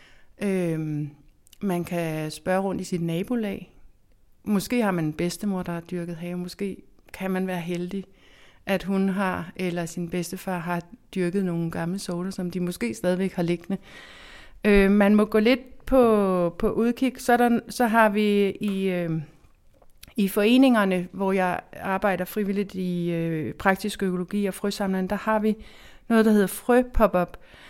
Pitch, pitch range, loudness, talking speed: 190 Hz, 175-210 Hz, -25 LUFS, 155 wpm